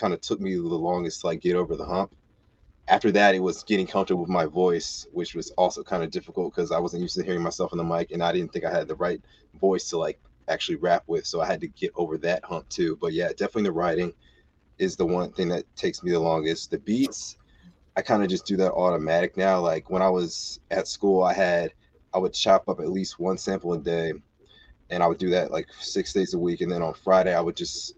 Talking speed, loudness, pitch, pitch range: 255 wpm, -26 LUFS, 90 Hz, 85-95 Hz